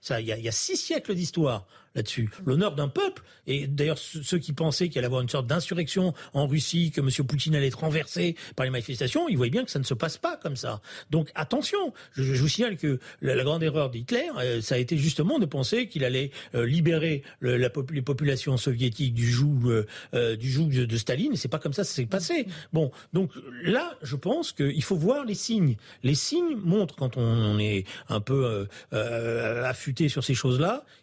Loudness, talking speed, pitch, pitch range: -27 LUFS, 200 wpm, 140 Hz, 125-165 Hz